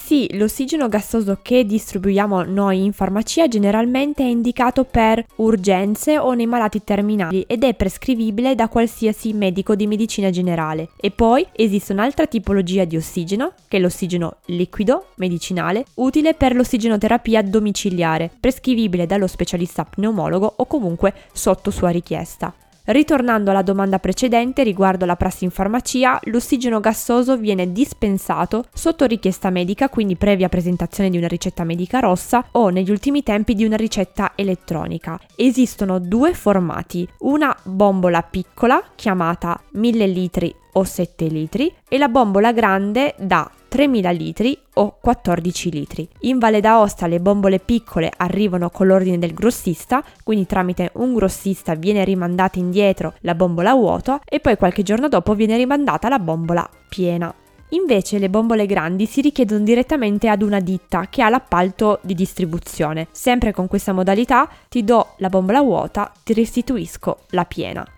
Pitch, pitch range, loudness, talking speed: 205 Hz, 185-240 Hz, -18 LUFS, 145 wpm